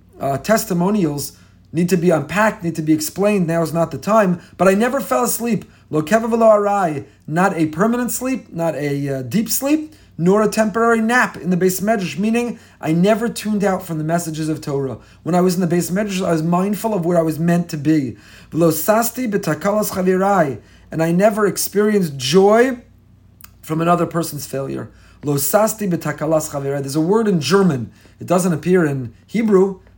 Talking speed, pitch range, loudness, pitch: 175 wpm, 155-210 Hz, -18 LUFS, 175 Hz